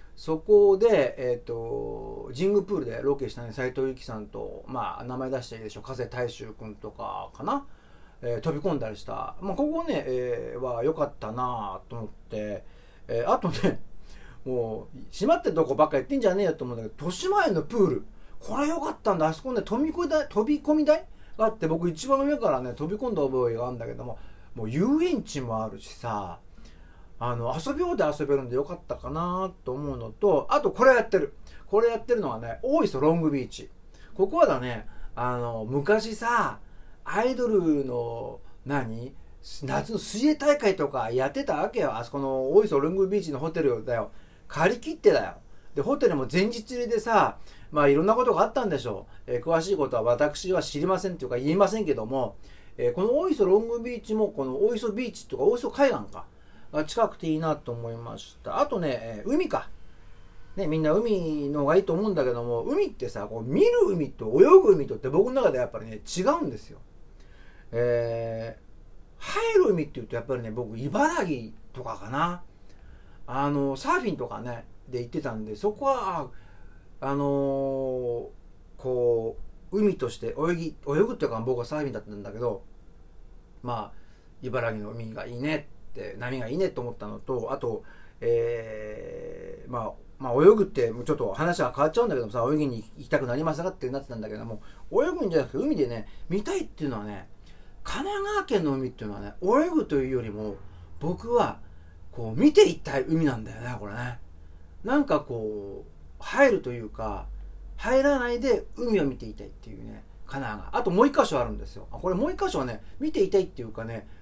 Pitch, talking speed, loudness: 135 Hz, 360 characters per minute, -27 LUFS